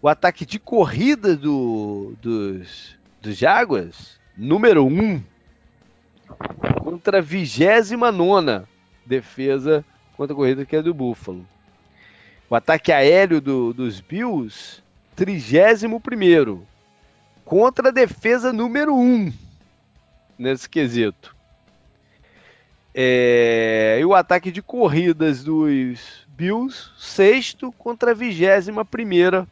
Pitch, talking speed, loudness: 160 Hz, 100 wpm, -18 LUFS